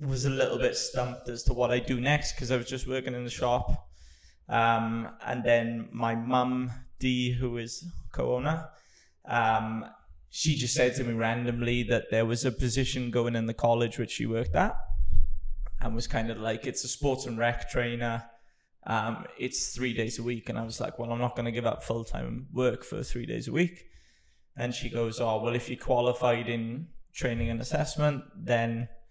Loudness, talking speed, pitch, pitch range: -30 LUFS, 200 wpm, 120 Hz, 115-125 Hz